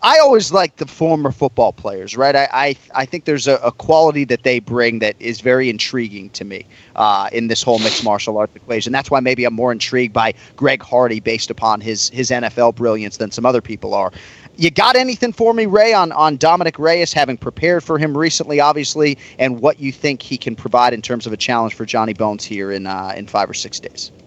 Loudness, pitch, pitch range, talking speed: -16 LUFS, 125 Hz, 115-150 Hz, 230 wpm